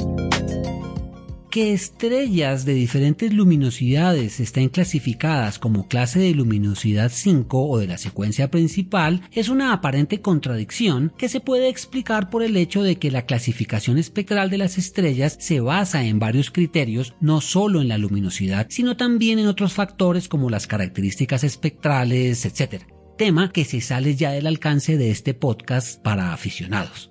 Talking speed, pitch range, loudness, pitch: 150 wpm, 120-185 Hz, -21 LUFS, 145 Hz